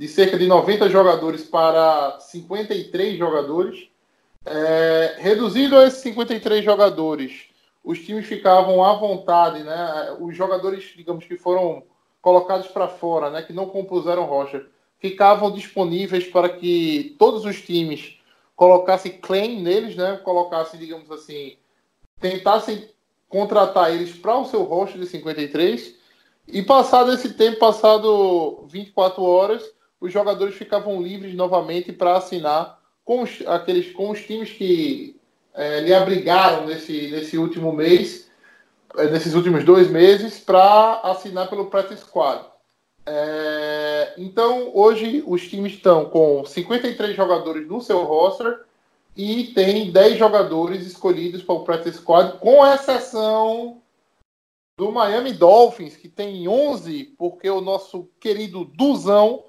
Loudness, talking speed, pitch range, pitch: -18 LUFS, 130 wpm, 170-215 Hz, 190 Hz